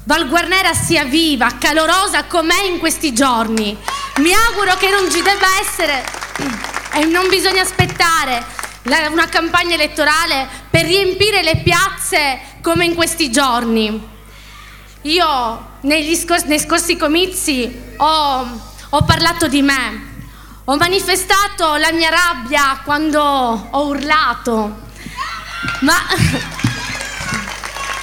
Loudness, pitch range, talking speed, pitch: -14 LUFS, 280-350 Hz, 110 wpm, 320 Hz